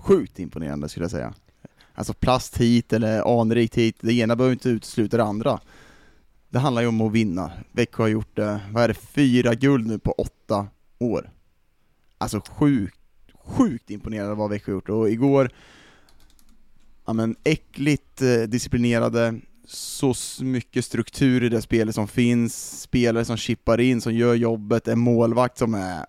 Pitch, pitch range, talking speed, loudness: 115 Hz, 105-125 Hz, 160 wpm, -23 LUFS